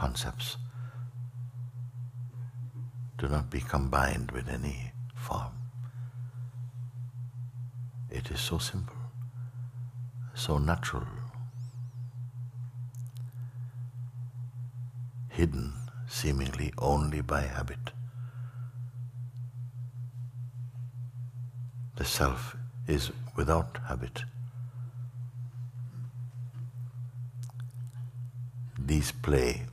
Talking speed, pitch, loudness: 50 wpm, 125 Hz, -36 LUFS